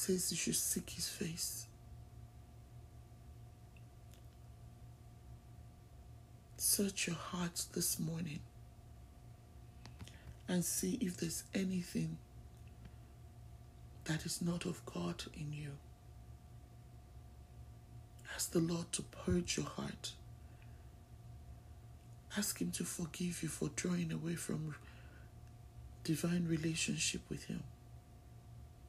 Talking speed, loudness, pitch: 90 wpm, -39 LUFS, 145 Hz